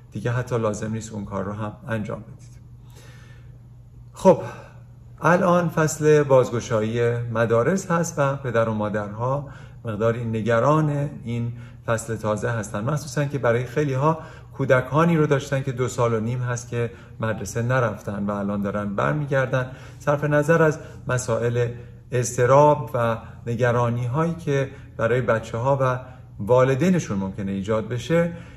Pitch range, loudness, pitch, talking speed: 115-135 Hz, -23 LUFS, 120 Hz, 135 wpm